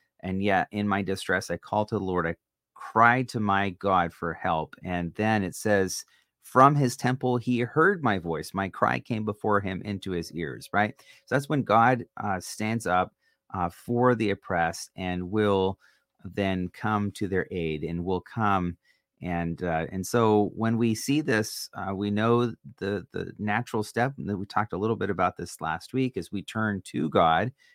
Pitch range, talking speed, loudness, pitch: 90-115 Hz, 190 wpm, -27 LUFS, 100 Hz